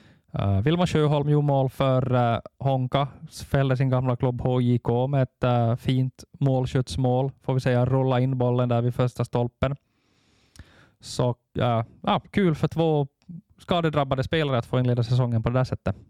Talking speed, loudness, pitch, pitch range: 160 wpm, -24 LUFS, 130 Hz, 125-140 Hz